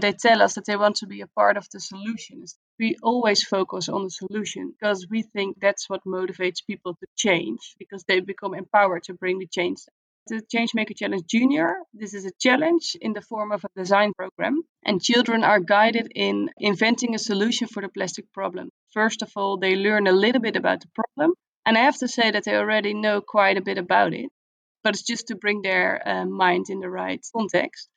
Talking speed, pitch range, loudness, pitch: 215 wpm, 190-225 Hz, -23 LUFS, 205 Hz